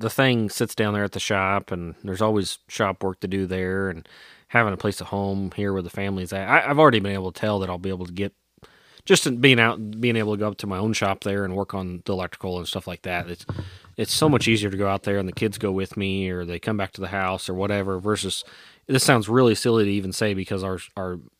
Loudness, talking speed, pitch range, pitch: -23 LUFS, 270 wpm, 95-110 Hz, 100 Hz